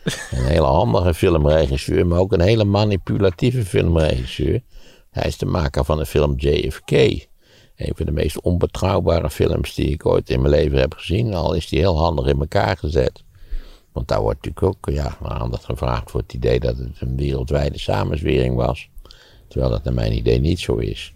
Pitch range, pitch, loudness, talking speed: 70-95 Hz, 80 Hz, -20 LUFS, 185 wpm